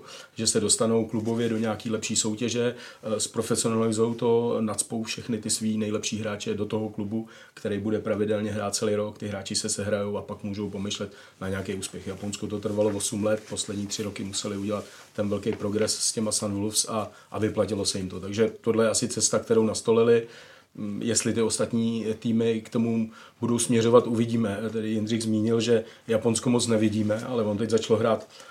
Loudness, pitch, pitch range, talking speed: -26 LUFS, 110 Hz, 105-115 Hz, 185 wpm